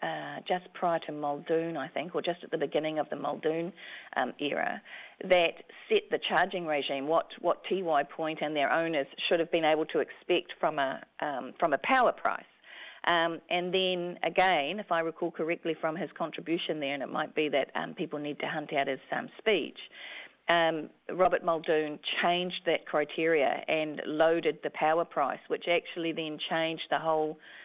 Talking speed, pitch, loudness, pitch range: 185 wpm, 165 Hz, -30 LUFS, 155-175 Hz